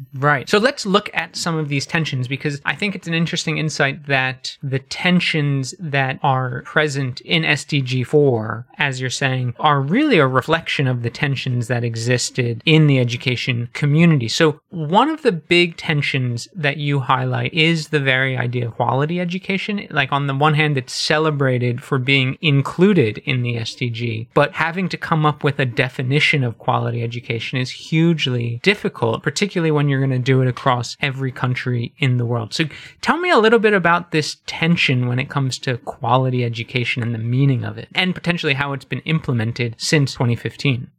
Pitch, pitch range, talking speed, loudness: 140 Hz, 125-160 Hz, 185 wpm, -18 LUFS